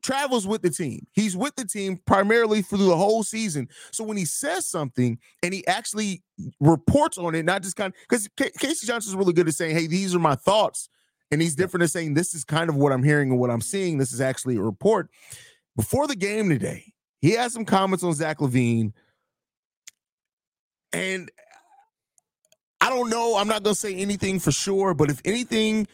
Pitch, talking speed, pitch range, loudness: 190 Hz, 200 wpm, 160-220 Hz, -23 LUFS